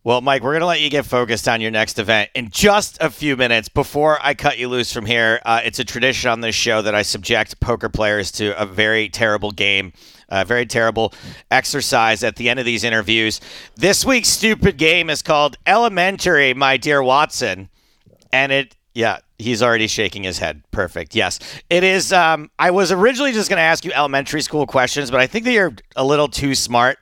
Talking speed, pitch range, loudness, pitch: 210 wpm, 110-150 Hz, -16 LUFS, 130 Hz